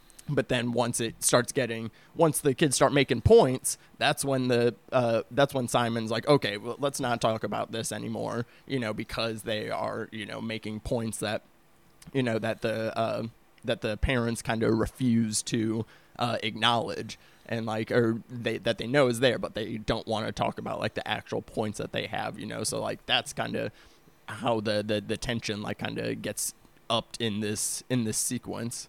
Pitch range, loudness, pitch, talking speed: 110-130 Hz, -28 LUFS, 115 Hz, 200 wpm